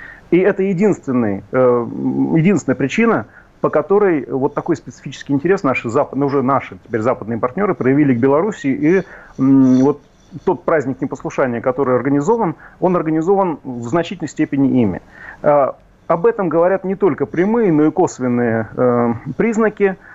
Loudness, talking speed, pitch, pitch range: -16 LUFS, 125 wpm, 145 Hz, 130-180 Hz